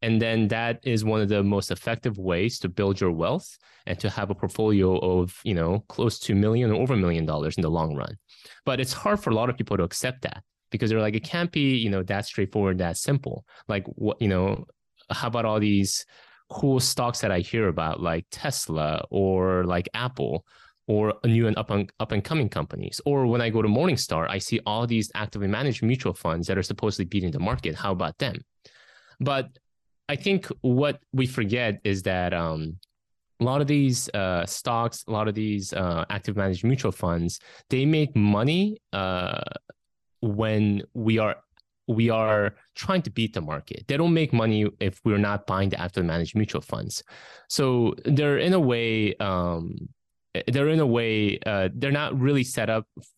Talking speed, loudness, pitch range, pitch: 200 wpm, -25 LUFS, 95-120 Hz, 105 Hz